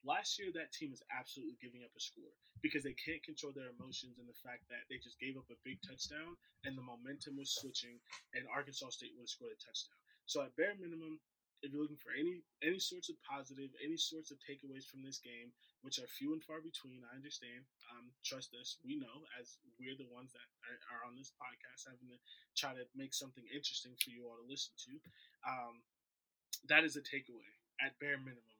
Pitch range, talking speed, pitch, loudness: 125-155 Hz, 215 wpm, 135 Hz, -44 LUFS